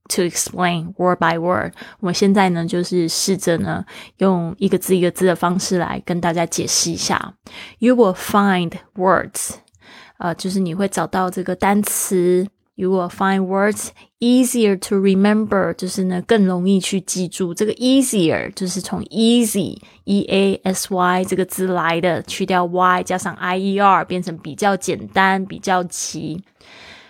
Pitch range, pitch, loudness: 180-195 Hz, 185 Hz, -18 LUFS